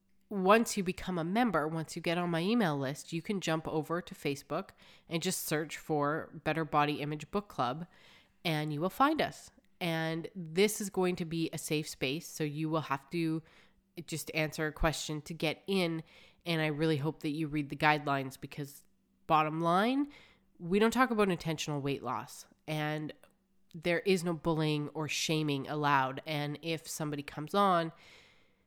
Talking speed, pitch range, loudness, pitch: 180 wpm, 150-180 Hz, -33 LUFS, 160 Hz